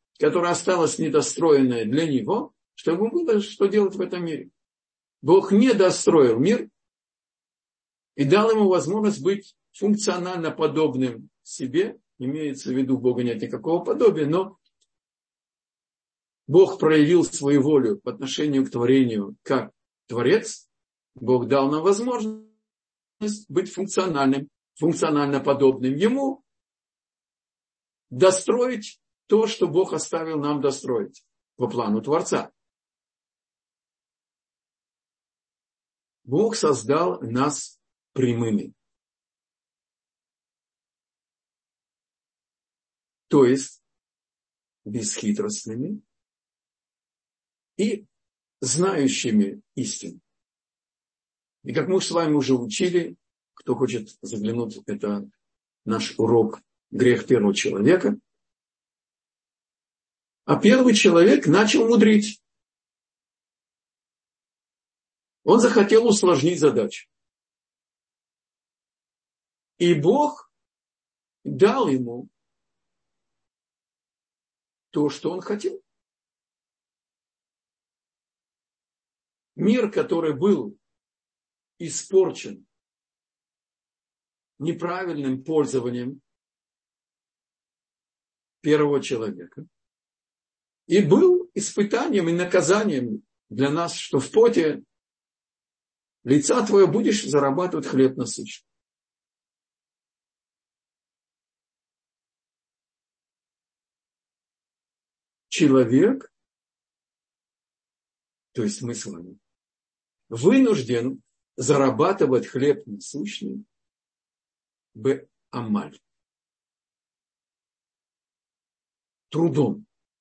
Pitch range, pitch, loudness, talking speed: 135-210 Hz, 170 Hz, -22 LUFS, 70 wpm